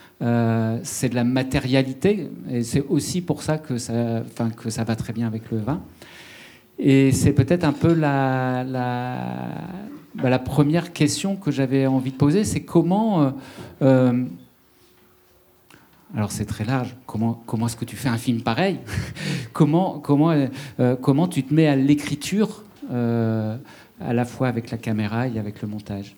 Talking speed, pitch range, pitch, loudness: 165 wpm, 115-145 Hz, 130 Hz, -22 LUFS